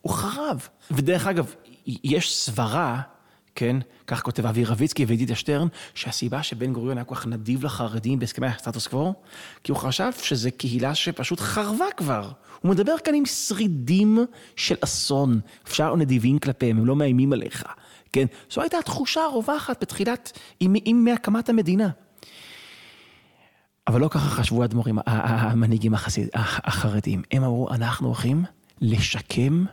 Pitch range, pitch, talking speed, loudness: 120-185 Hz, 135 Hz, 145 wpm, -24 LUFS